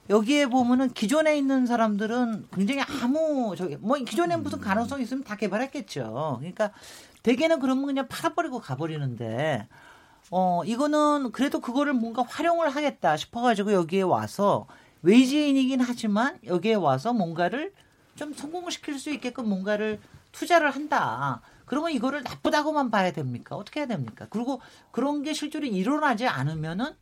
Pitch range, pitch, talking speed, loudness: 205-290 Hz, 250 Hz, 365 characters per minute, -26 LUFS